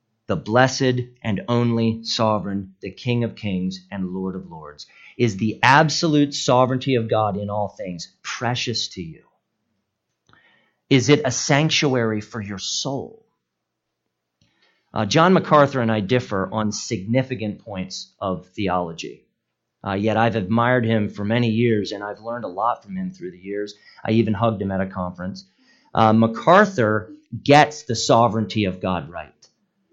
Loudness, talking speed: -21 LUFS, 150 wpm